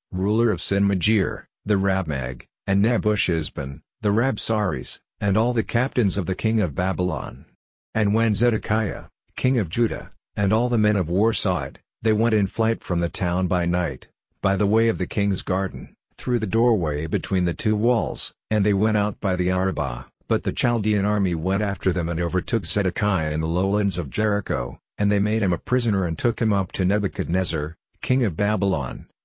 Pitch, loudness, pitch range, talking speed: 100 Hz, -23 LUFS, 90-110 Hz, 190 wpm